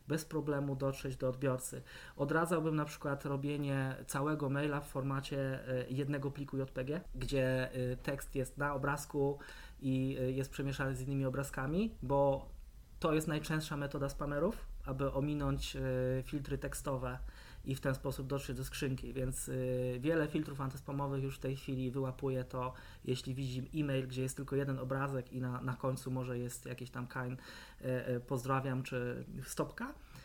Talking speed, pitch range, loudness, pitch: 155 wpm, 130-140 Hz, -38 LUFS, 135 Hz